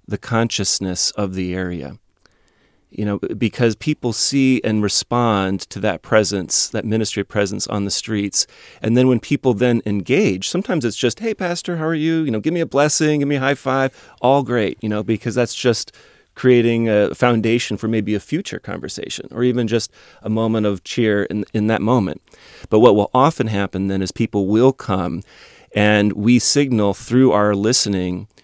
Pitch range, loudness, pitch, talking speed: 100-125 Hz, -18 LUFS, 110 Hz, 185 wpm